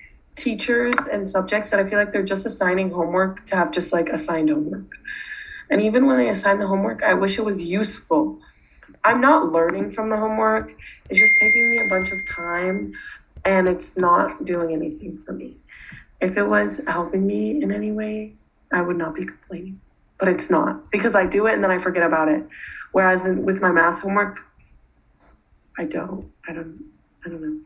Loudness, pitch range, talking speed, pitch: -20 LUFS, 170-215 Hz, 190 wpm, 190 Hz